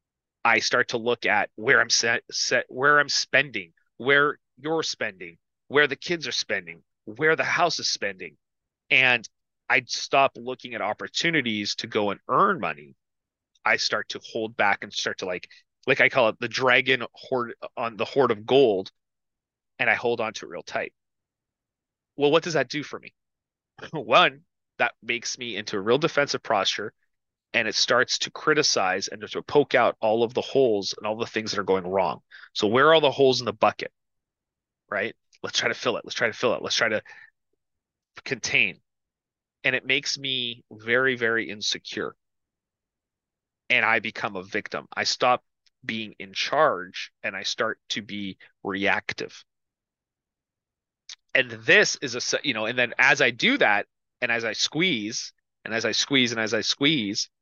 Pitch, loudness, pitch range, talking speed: 120 Hz, -23 LUFS, 110-140 Hz, 180 wpm